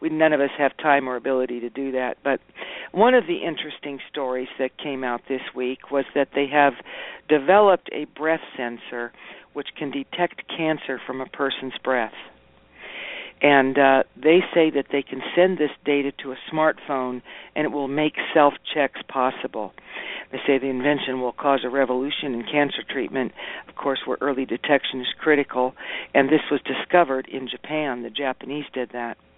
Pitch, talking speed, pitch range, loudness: 140 Hz, 175 wpm, 130-150 Hz, -23 LUFS